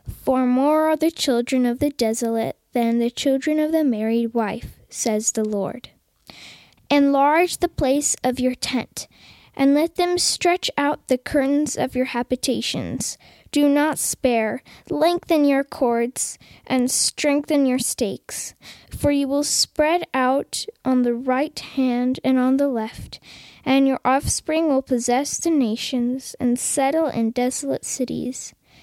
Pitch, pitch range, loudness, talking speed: 265 Hz, 250-295 Hz, -21 LUFS, 145 wpm